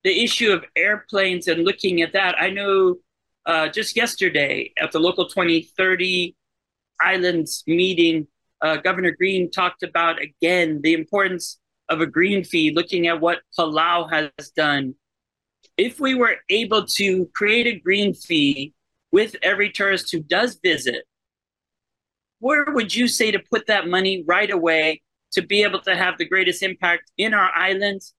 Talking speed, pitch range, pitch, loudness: 155 wpm, 165-205 Hz, 185 Hz, -20 LUFS